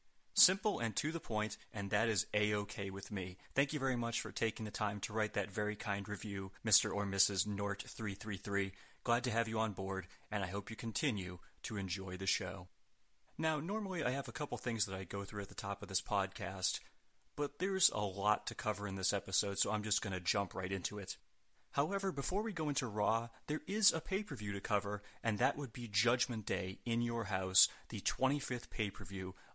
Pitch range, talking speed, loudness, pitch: 100-125 Hz, 210 wpm, -36 LUFS, 105 Hz